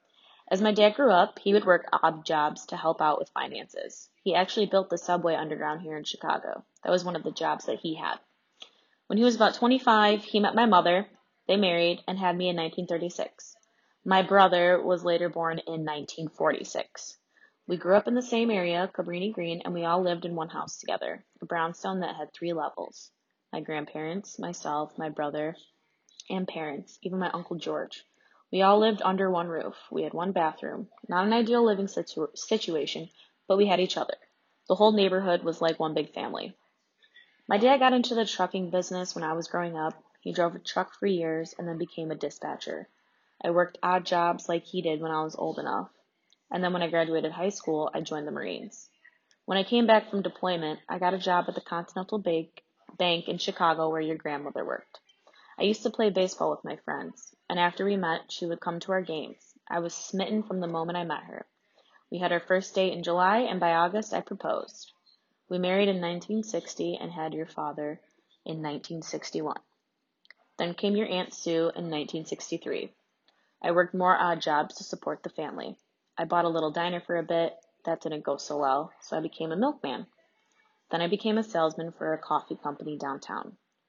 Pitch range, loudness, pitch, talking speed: 160-195 Hz, -28 LUFS, 175 Hz, 200 wpm